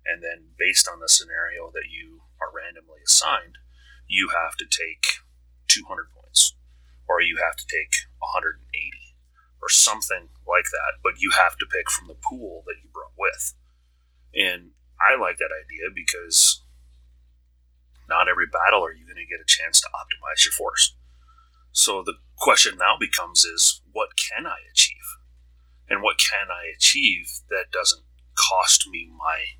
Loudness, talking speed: -20 LUFS, 160 wpm